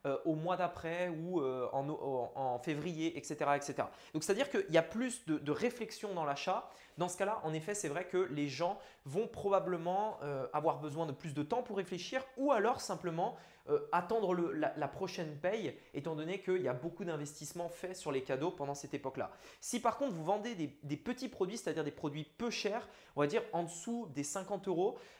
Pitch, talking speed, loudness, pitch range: 175 Hz, 200 wpm, -38 LUFS, 150-205 Hz